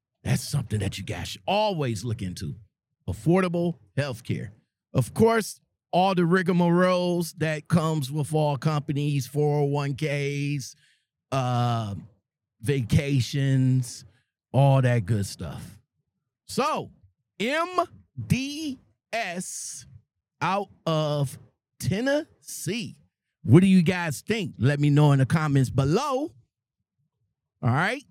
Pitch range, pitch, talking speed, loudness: 125-175 Hz, 145 Hz, 100 wpm, -25 LUFS